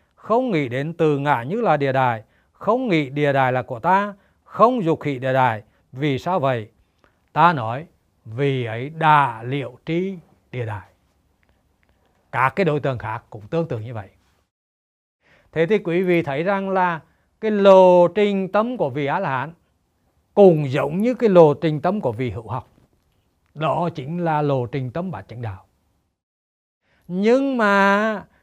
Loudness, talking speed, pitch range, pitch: -20 LUFS, 170 wpm, 110-175 Hz, 140 Hz